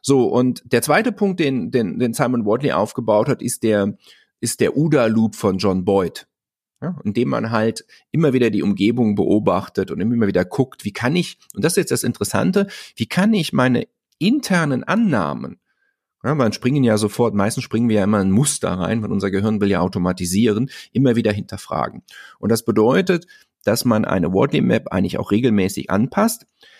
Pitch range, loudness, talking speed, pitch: 105-150 Hz, -19 LUFS, 185 wpm, 120 Hz